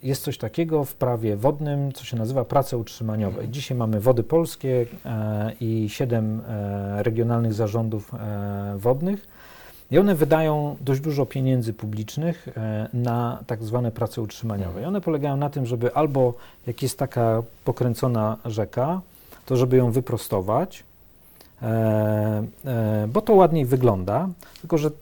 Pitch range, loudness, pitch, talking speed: 110-140 Hz, -24 LUFS, 120 Hz, 130 wpm